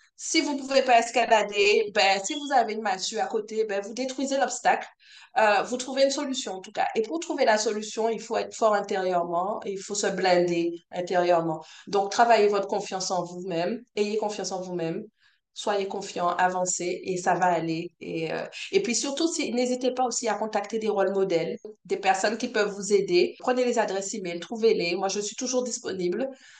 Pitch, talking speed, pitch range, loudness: 210 Hz, 200 wpm, 190-250 Hz, -26 LUFS